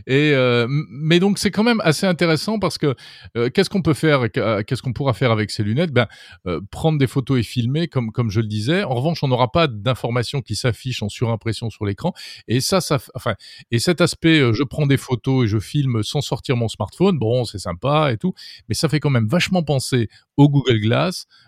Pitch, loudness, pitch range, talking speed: 130 Hz, -19 LUFS, 115-155 Hz, 225 wpm